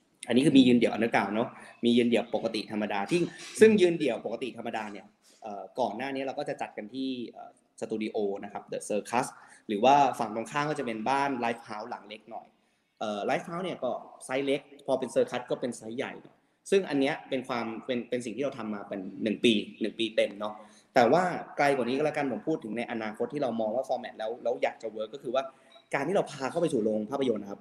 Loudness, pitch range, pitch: -29 LUFS, 110-135 Hz, 120 Hz